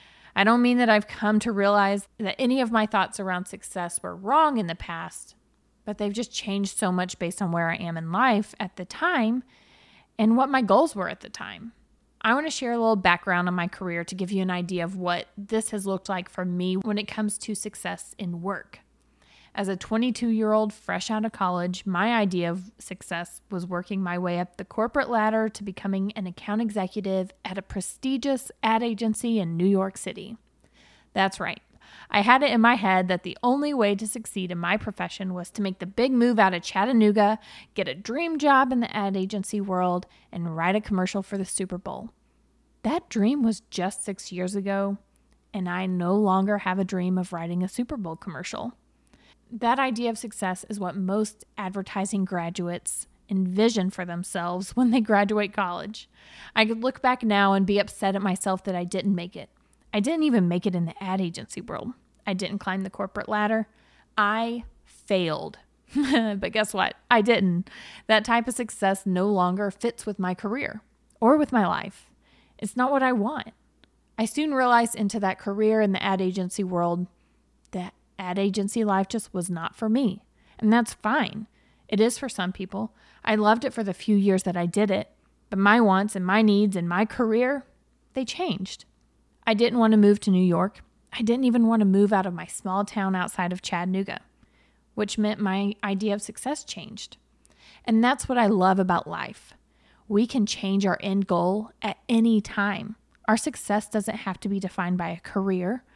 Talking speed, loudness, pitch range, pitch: 200 wpm, -25 LUFS, 185-225 Hz, 205 Hz